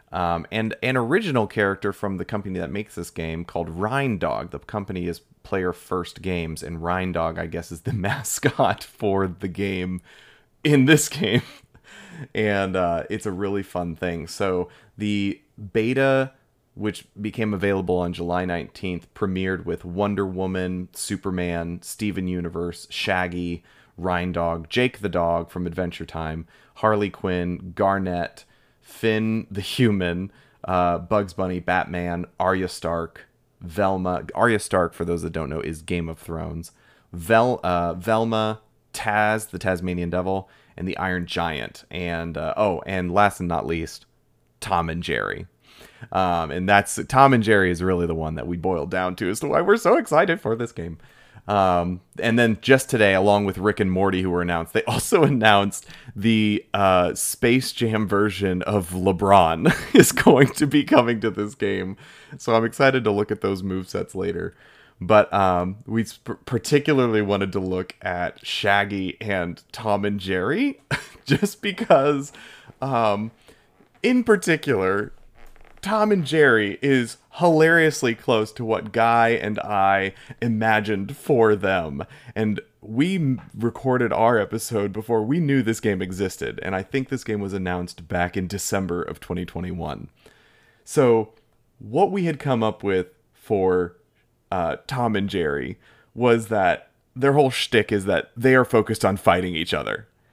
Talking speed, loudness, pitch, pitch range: 155 wpm, -22 LUFS, 100 Hz, 90-115 Hz